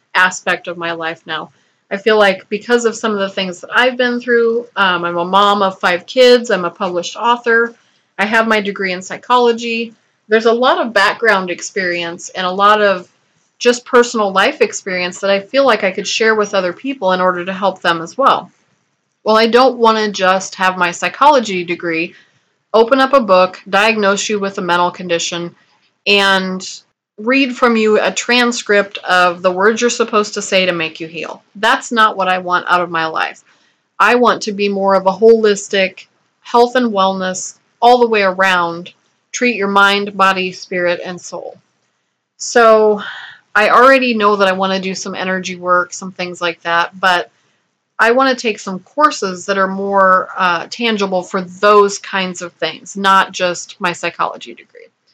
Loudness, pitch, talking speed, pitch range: -14 LUFS, 195 Hz, 185 wpm, 185-225 Hz